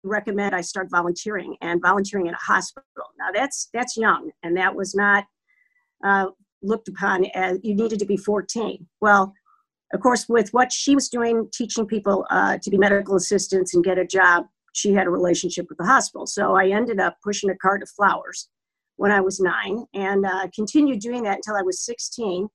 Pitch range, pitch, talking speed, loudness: 190-225 Hz, 200 Hz, 195 wpm, -21 LUFS